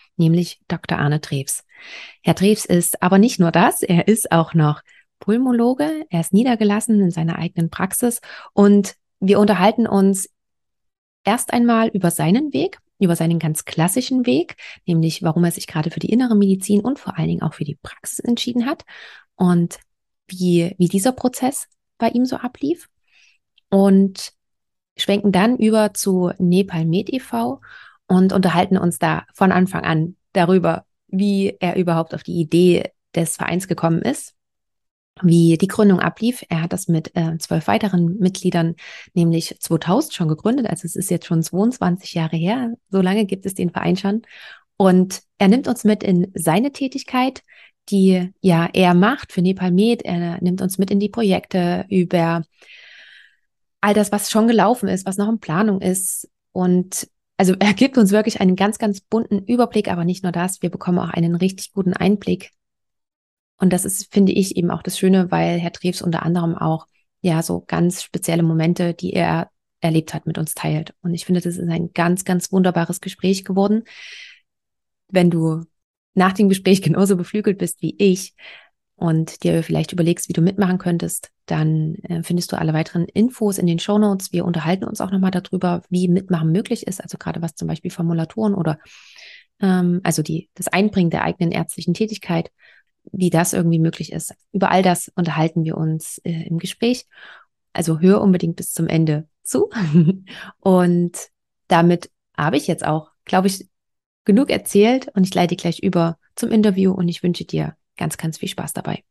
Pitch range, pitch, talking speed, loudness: 170-205 Hz, 185 Hz, 175 wpm, -19 LUFS